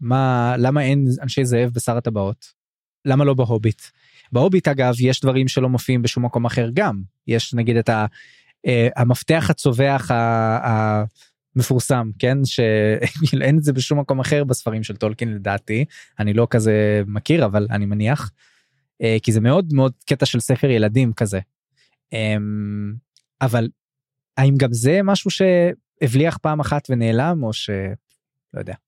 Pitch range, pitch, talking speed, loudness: 115-140 Hz, 125 Hz, 145 wpm, -19 LUFS